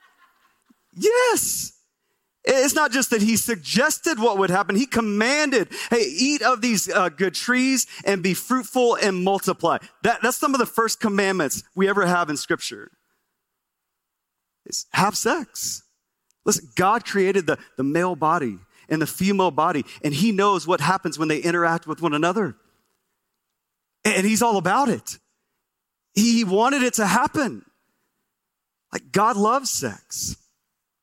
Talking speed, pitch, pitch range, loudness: 145 wpm, 210 Hz, 180-250 Hz, -21 LUFS